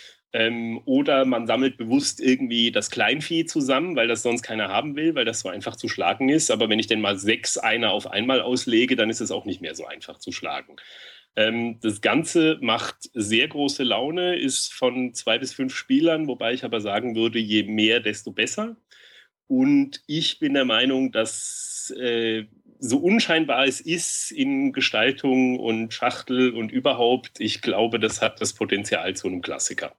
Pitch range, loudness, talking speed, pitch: 115-160 Hz, -23 LUFS, 180 wpm, 125 Hz